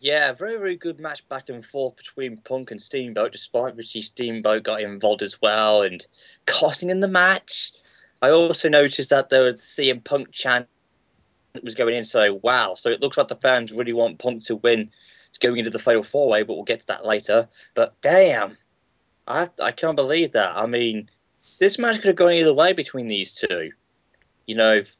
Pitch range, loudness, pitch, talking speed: 110-145 Hz, -21 LUFS, 125 Hz, 200 wpm